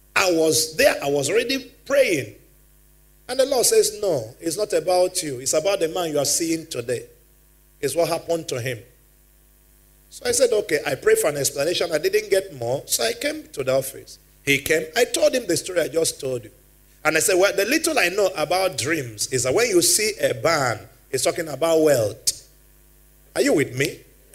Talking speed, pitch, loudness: 205 wpm, 170 Hz, -21 LUFS